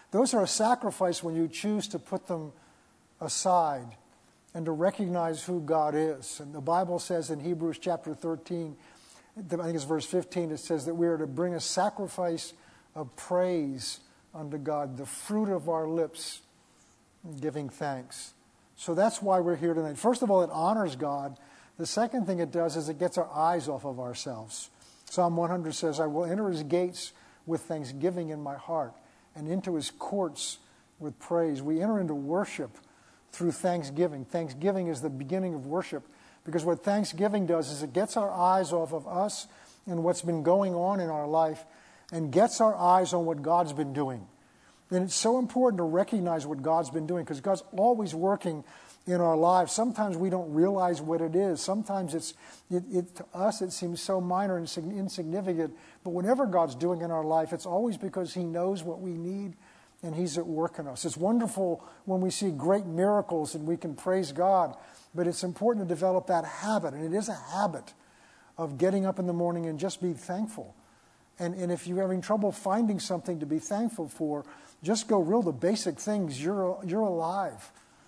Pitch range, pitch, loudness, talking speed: 160-190 Hz, 175 Hz, -30 LUFS, 190 wpm